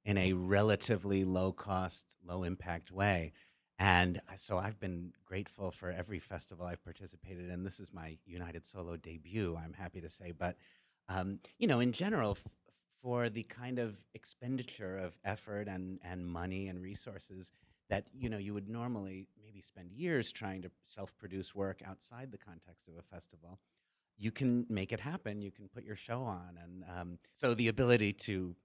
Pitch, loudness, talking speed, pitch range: 95 Hz, -38 LUFS, 180 wpm, 90-105 Hz